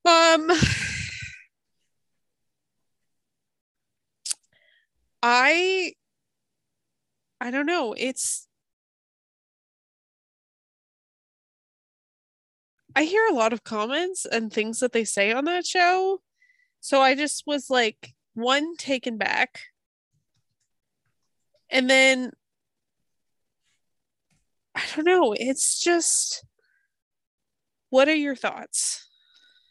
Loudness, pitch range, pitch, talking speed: -23 LUFS, 250-355 Hz, 290 Hz, 80 wpm